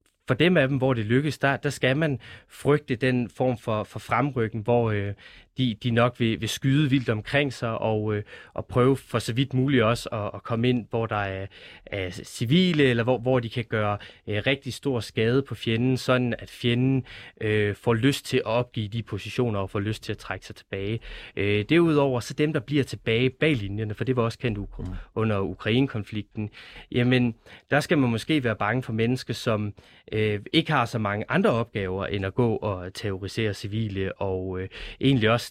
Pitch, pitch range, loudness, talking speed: 115 Hz, 105-130 Hz, -25 LUFS, 205 wpm